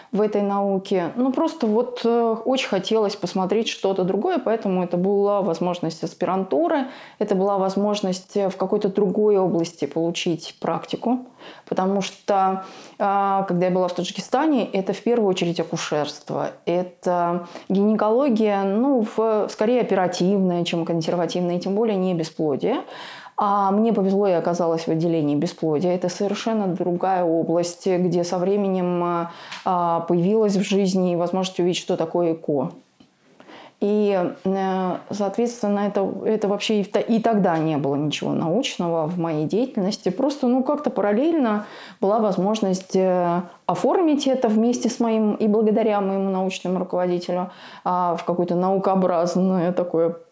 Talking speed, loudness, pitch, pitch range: 130 wpm, -22 LUFS, 195 Hz, 175-215 Hz